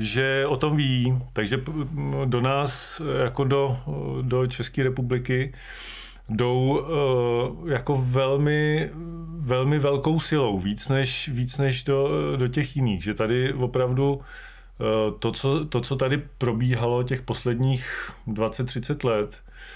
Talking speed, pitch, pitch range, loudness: 120 wpm, 130 Hz, 125-140 Hz, -25 LUFS